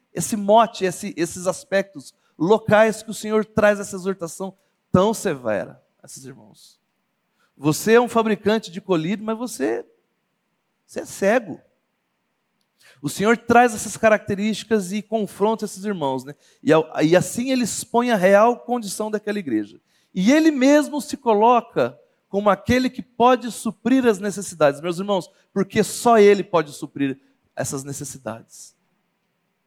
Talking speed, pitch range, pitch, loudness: 140 wpm, 185-225 Hz, 205 Hz, -20 LUFS